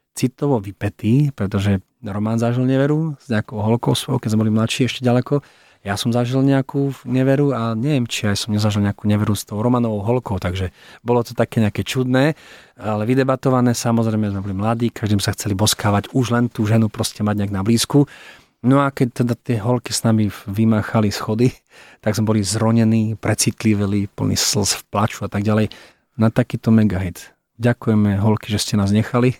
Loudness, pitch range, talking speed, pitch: -19 LUFS, 105-125 Hz, 185 wpm, 110 Hz